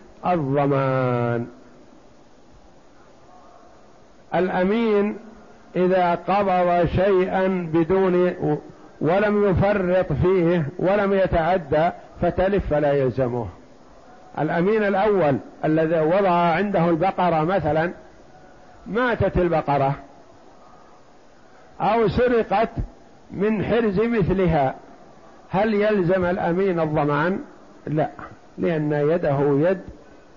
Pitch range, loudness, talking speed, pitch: 155-195 Hz, -21 LUFS, 70 wpm, 180 Hz